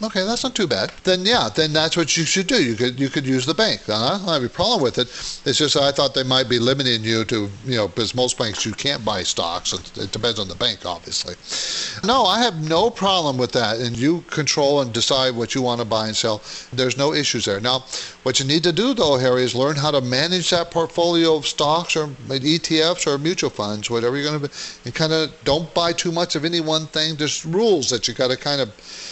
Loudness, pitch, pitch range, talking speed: -19 LUFS, 140 Hz, 125-165 Hz, 250 wpm